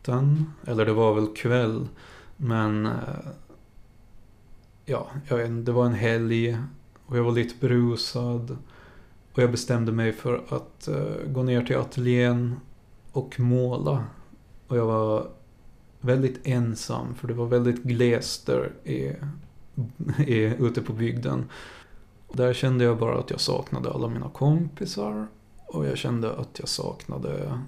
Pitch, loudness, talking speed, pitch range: 120 Hz, -26 LUFS, 130 wpm, 110-125 Hz